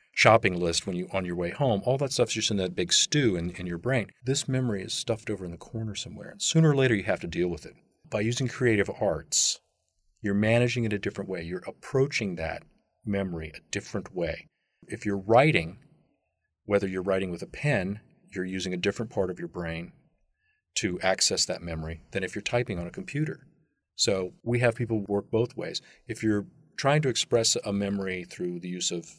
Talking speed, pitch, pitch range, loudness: 210 wpm, 100 Hz, 90-120 Hz, -28 LUFS